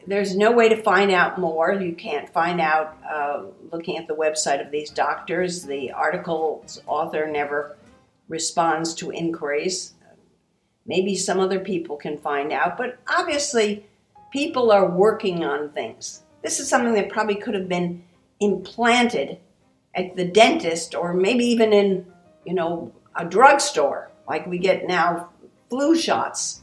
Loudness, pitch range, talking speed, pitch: -22 LUFS, 165-210 Hz, 150 wpm, 185 Hz